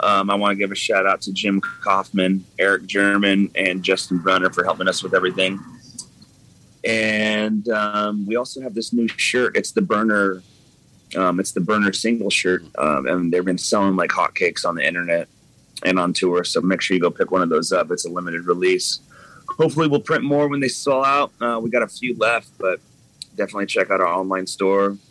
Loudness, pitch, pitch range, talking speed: -20 LUFS, 100 Hz, 95-120 Hz, 205 wpm